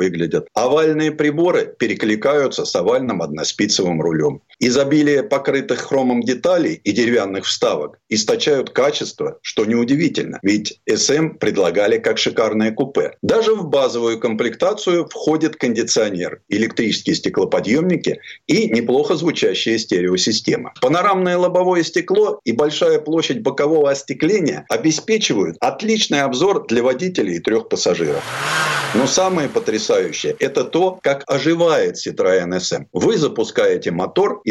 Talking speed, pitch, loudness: 115 wpm, 180 Hz, -17 LUFS